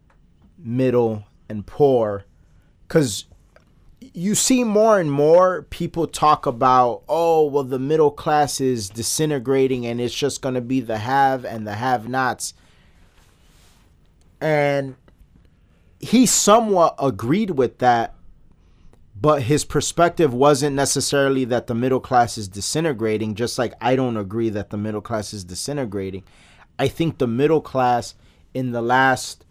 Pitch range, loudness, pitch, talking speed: 110-145 Hz, -20 LUFS, 130 Hz, 135 wpm